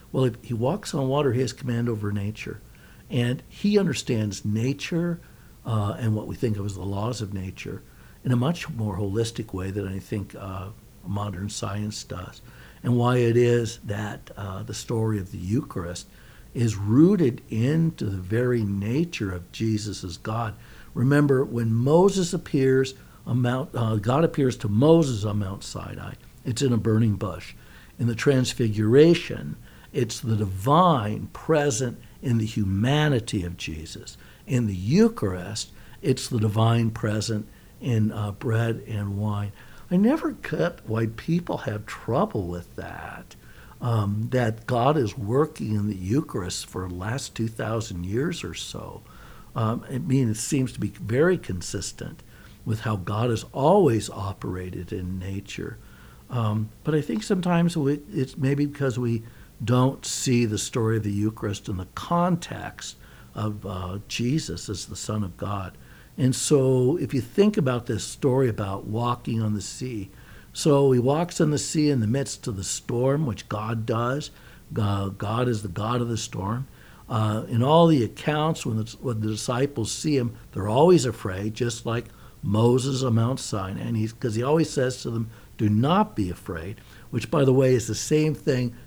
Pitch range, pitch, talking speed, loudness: 105-130 Hz, 115 Hz, 170 wpm, -25 LUFS